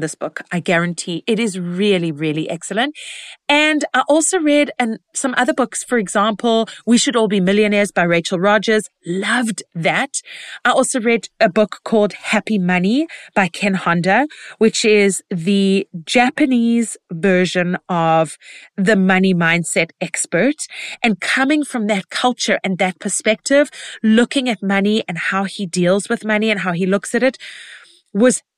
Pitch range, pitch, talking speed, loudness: 185-240 Hz, 210 Hz, 155 wpm, -17 LUFS